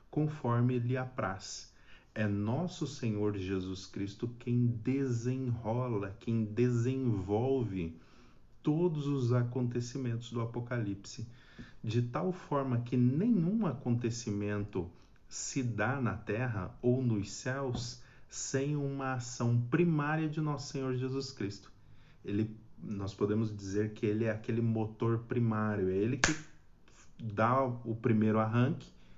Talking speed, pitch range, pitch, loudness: 115 wpm, 105-130 Hz, 120 Hz, -34 LUFS